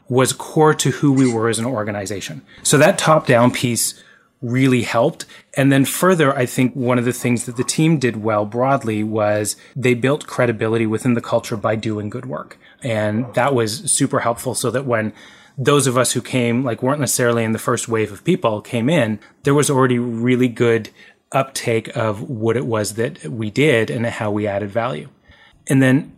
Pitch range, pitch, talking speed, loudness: 115-130 Hz, 120 Hz, 195 wpm, -18 LUFS